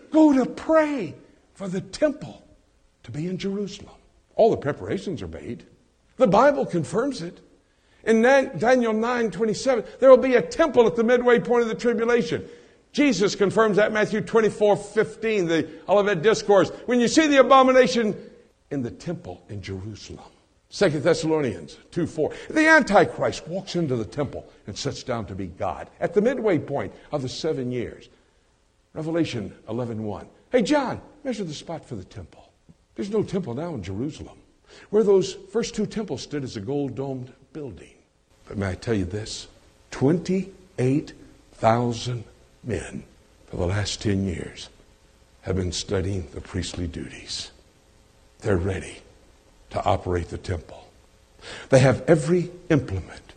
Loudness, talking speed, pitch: -23 LUFS, 150 wpm, 175 Hz